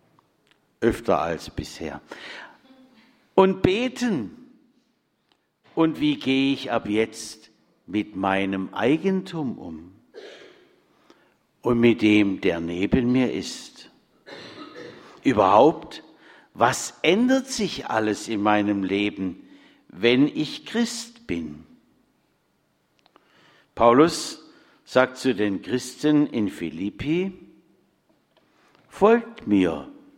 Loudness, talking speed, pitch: -23 LUFS, 85 wpm, 150 Hz